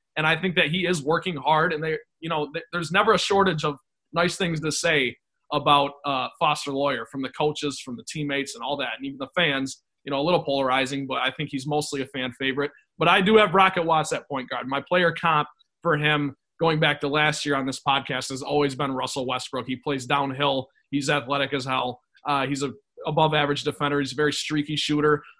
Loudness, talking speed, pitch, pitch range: -24 LUFS, 225 wpm, 145 Hz, 140-160 Hz